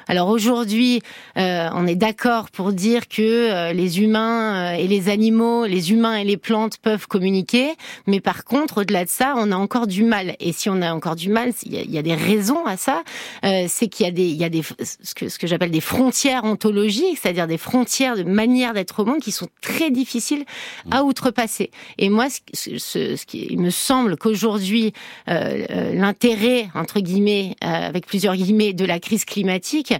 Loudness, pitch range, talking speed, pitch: -20 LUFS, 185-235 Hz, 200 wpm, 215 Hz